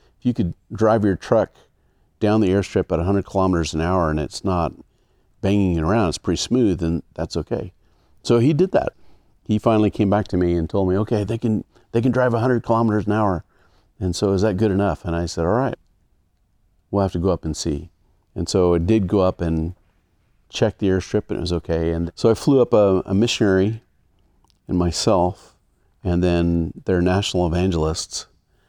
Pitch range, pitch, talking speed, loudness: 85-105 Hz, 95 Hz, 200 wpm, -20 LUFS